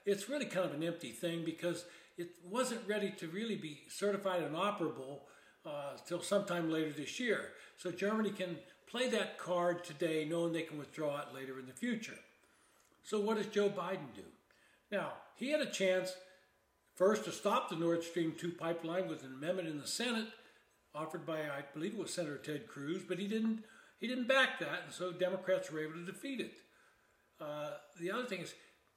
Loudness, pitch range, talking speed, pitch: -39 LUFS, 160-205 Hz, 195 wpm, 180 Hz